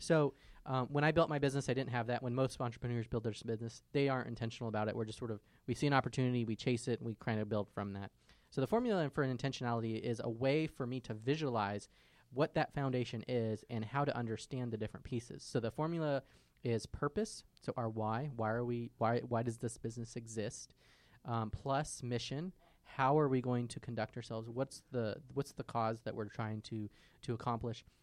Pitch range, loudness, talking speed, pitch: 115-135 Hz, -38 LUFS, 220 wpm, 120 Hz